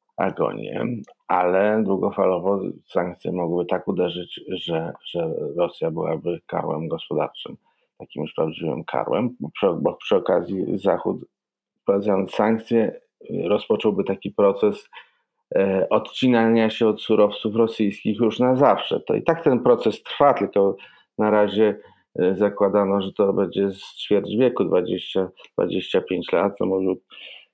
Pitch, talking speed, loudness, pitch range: 105 Hz, 120 wpm, -22 LUFS, 100-120 Hz